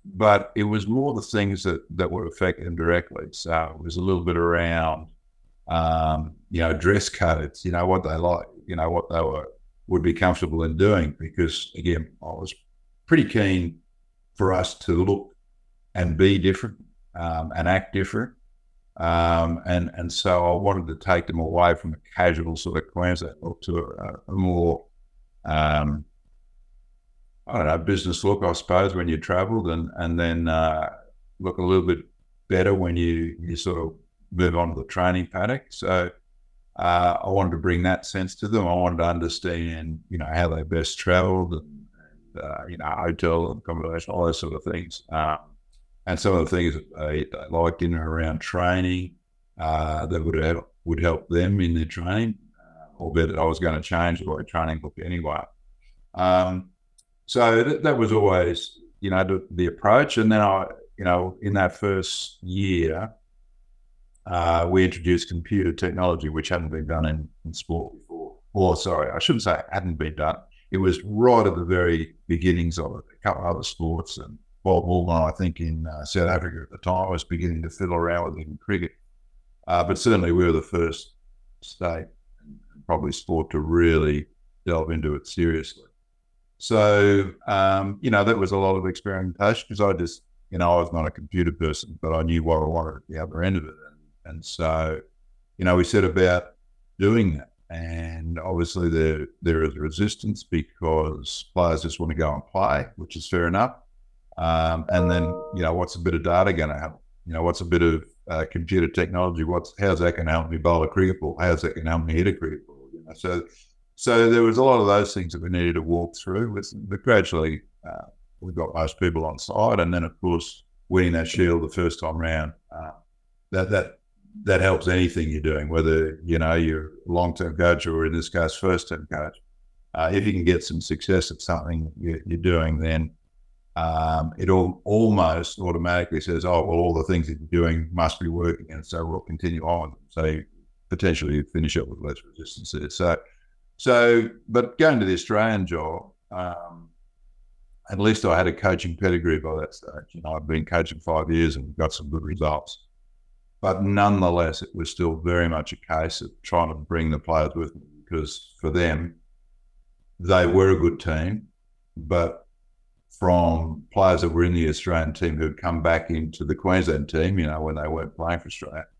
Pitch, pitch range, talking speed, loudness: 85 Hz, 80-95 Hz, 195 wpm, -24 LUFS